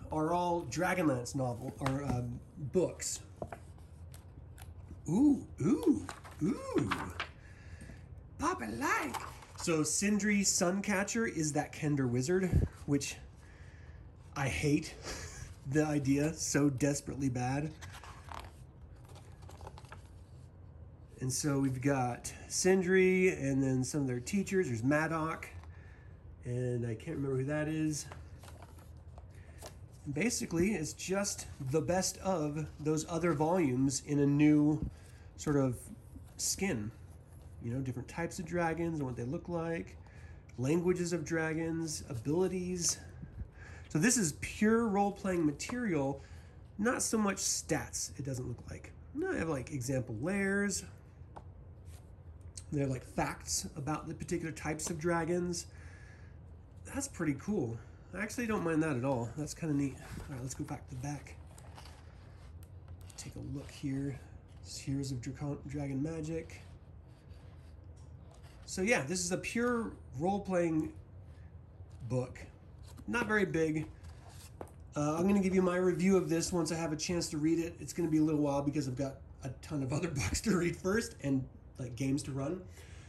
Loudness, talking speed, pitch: -34 LUFS, 135 wpm, 135 Hz